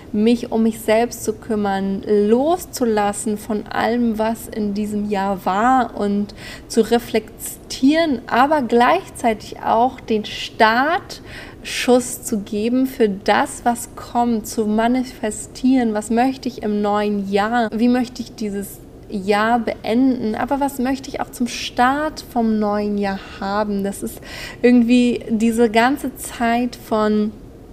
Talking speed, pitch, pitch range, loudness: 130 wpm, 225 Hz, 210-245 Hz, -19 LUFS